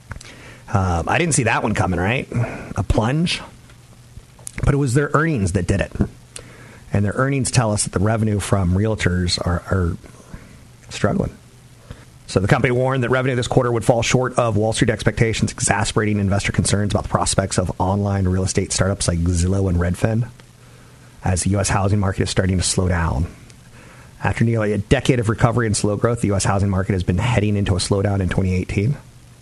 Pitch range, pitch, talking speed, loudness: 95-120 Hz, 105 Hz, 190 wpm, -19 LUFS